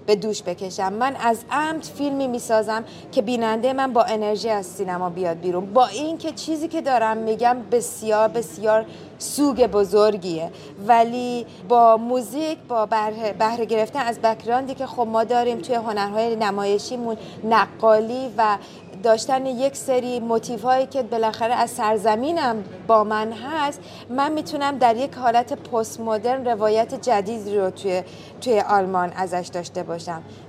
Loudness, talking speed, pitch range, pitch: -22 LUFS, 145 wpm, 210-250 Hz, 225 Hz